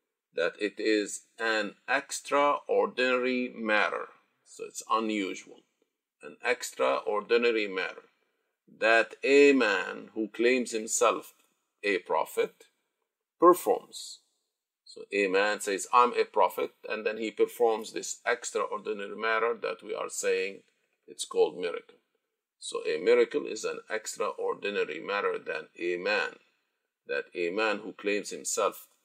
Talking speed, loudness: 120 wpm, -29 LUFS